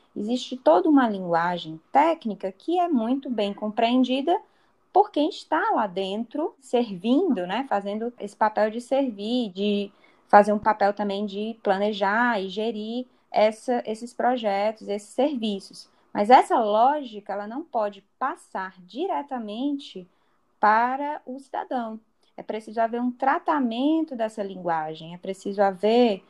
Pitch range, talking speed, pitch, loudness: 205-265 Hz, 130 wpm, 225 Hz, -24 LUFS